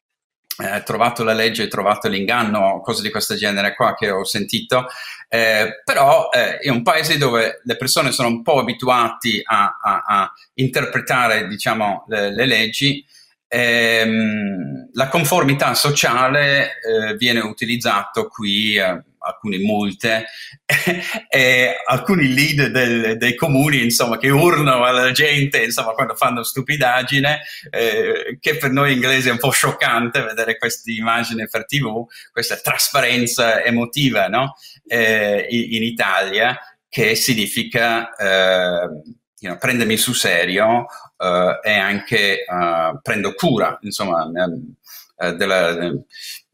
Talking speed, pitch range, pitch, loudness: 130 wpm, 110-140 Hz, 120 Hz, -17 LUFS